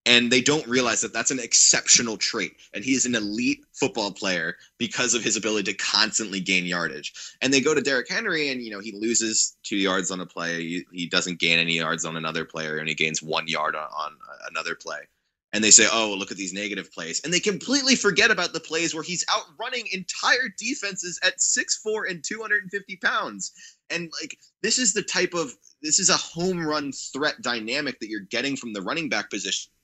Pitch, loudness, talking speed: 130 Hz, -23 LUFS, 215 wpm